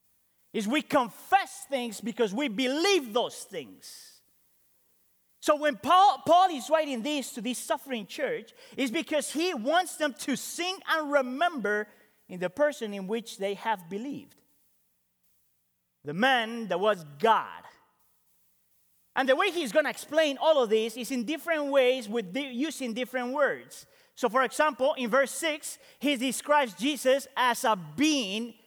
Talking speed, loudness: 150 wpm, -28 LUFS